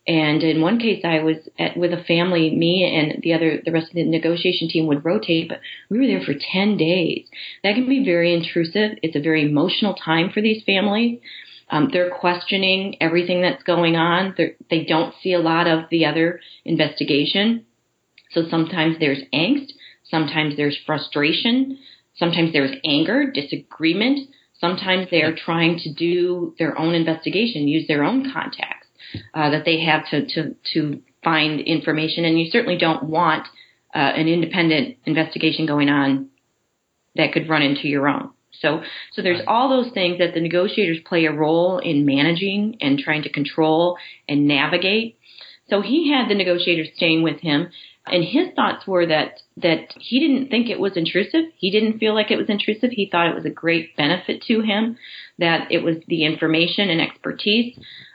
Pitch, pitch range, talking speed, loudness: 170 Hz, 160-195 Hz, 175 wpm, -19 LUFS